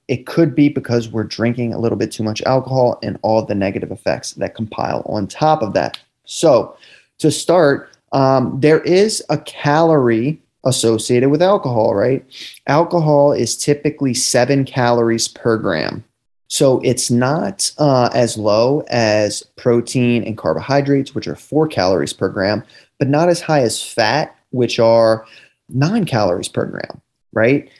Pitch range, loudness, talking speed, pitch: 115-145 Hz, -16 LUFS, 155 wpm, 125 Hz